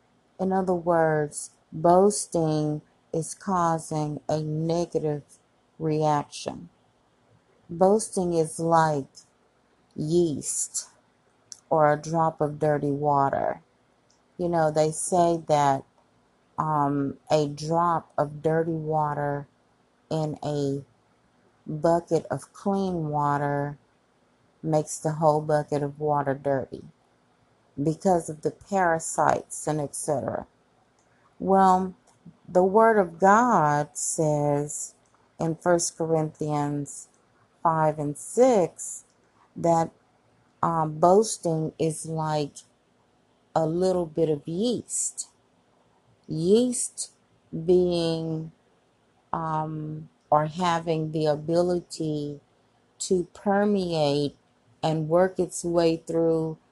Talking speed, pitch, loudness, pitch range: 90 wpm, 160 Hz, -25 LUFS, 150-170 Hz